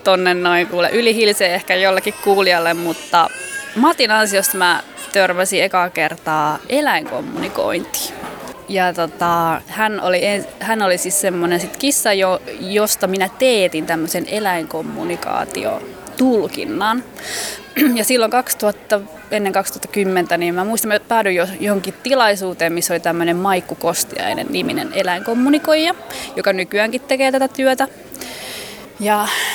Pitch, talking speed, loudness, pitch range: 195 Hz, 115 wpm, -17 LUFS, 180-225 Hz